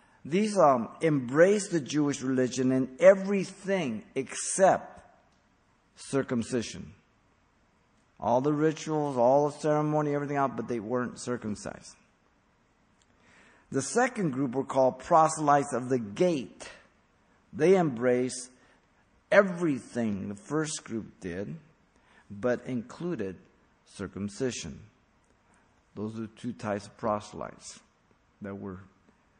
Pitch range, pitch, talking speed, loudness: 115-160 Hz, 130 Hz, 100 wpm, -28 LUFS